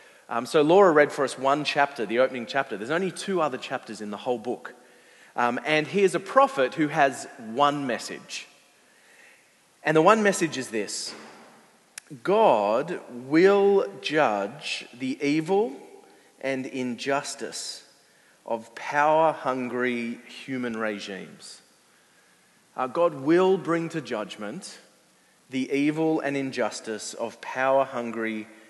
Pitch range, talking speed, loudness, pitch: 125-160 Hz, 125 wpm, -25 LUFS, 140 Hz